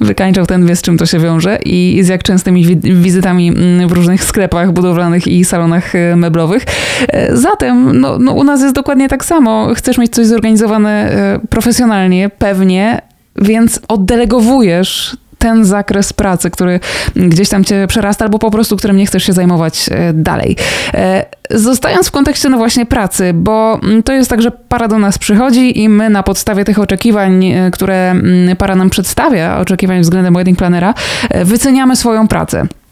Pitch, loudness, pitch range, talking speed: 195 Hz, -10 LUFS, 180-225 Hz, 155 wpm